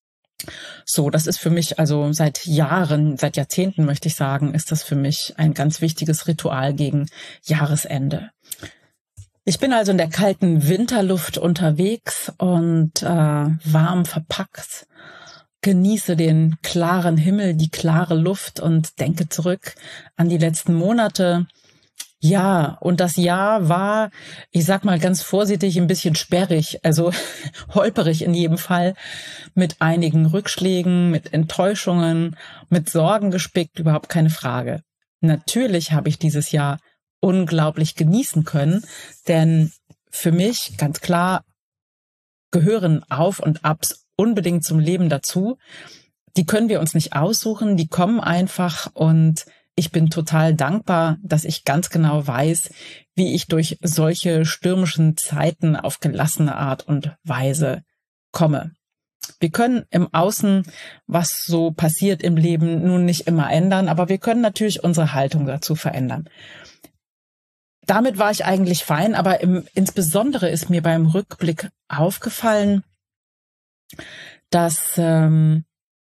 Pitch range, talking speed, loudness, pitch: 155-185 Hz, 130 wpm, -19 LUFS, 165 Hz